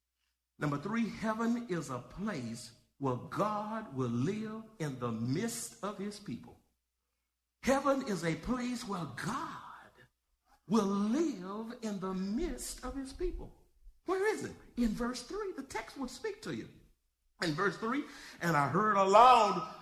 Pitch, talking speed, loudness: 205 Hz, 150 wpm, -34 LUFS